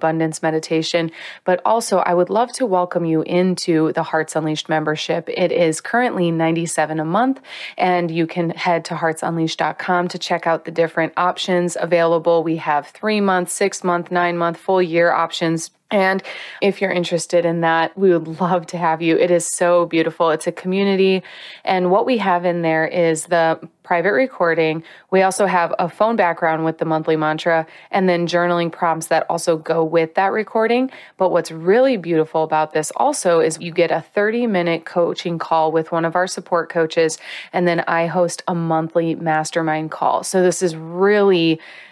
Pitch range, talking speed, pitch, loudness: 160-180 Hz, 175 wpm, 170 Hz, -18 LUFS